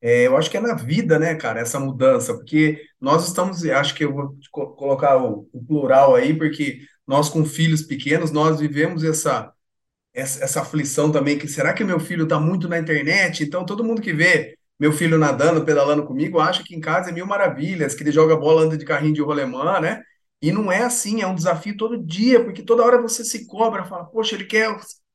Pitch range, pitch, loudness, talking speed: 150-200 Hz, 160 Hz, -19 LUFS, 215 wpm